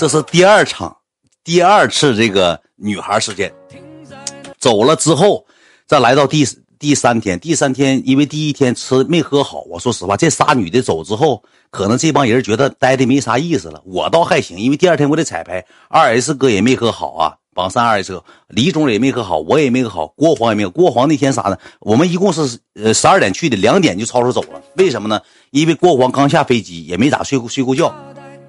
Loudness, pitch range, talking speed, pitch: -14 LUFS, 110-150 Hz, 310 characters per minute, 130 Hz